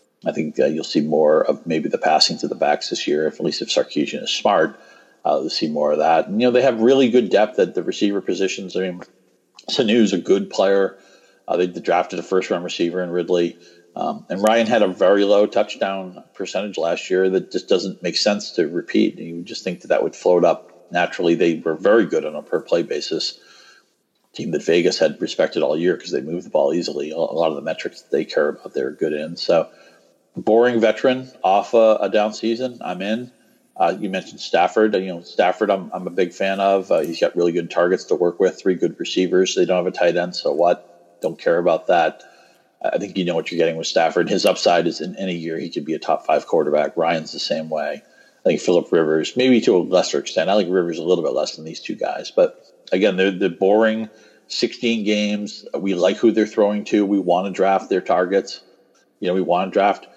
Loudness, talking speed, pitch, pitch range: -19 LUFS, 235 wpm, 100 Hz, 90-115 Hz